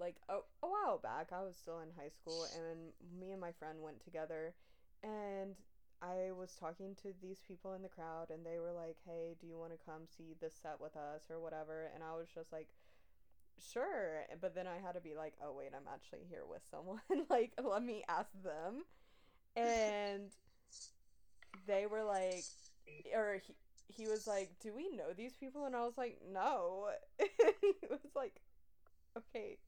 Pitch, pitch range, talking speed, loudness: 180 Hz, 160-210 Hz, 190 wpm, -44 LUFS